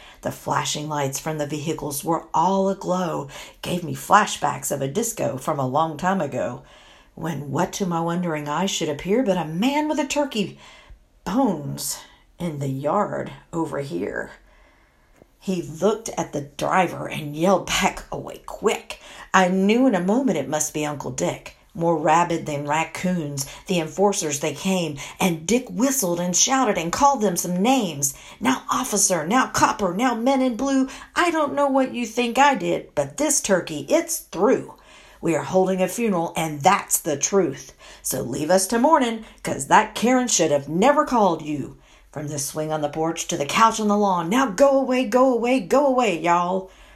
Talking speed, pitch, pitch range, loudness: 180 wpm, 185 Hz, 160-240 Hz, -22 LUFS